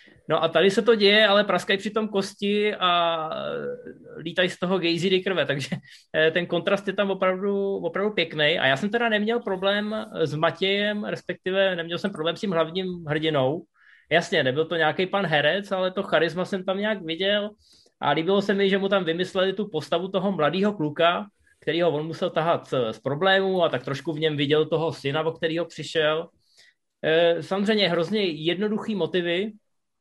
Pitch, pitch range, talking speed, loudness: 180 Hz, 160-200 Hz, 175 wpm, -24 LUFS